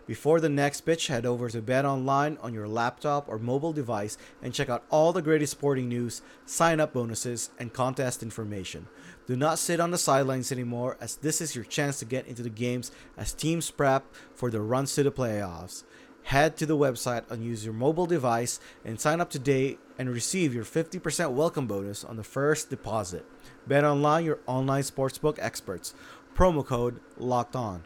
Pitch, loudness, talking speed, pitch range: 130 Hz, -28 LUFS, 185 wpm, 120-150 Hz